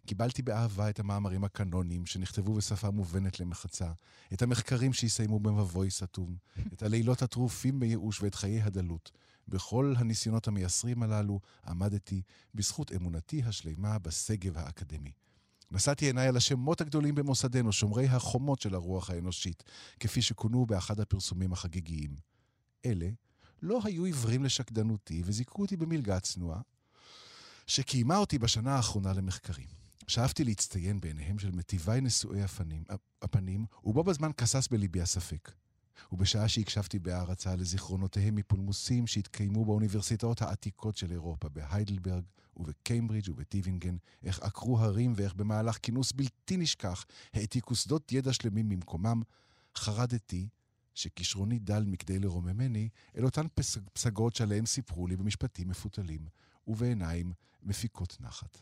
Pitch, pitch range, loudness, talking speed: 105 Hz, 95-120 Hz, -33 LUFS, 120 wpm